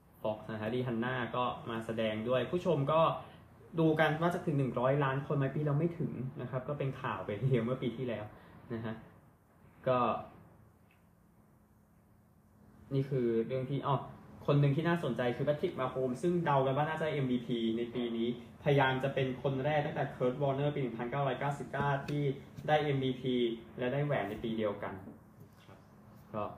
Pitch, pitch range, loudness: 130 Hz, 120-145 Hz, -34 LUFS